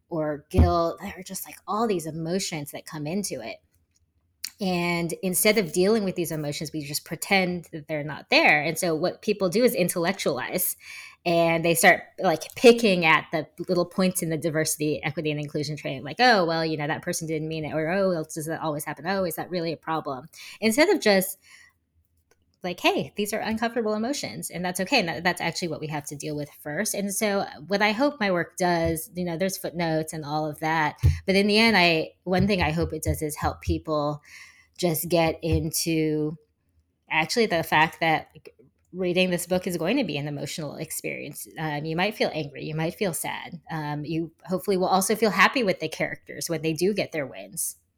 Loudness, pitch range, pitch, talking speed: -25 LUFS, 155-190 Hz, 165 Hz, 210 wpm